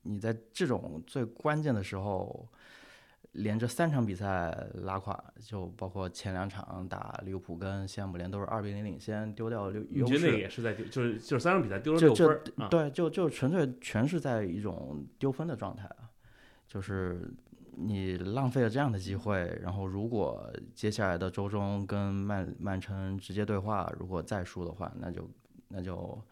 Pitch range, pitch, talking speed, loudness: 95-120 Hz, 105 Hz, 260 characters per minute, -33 LUFS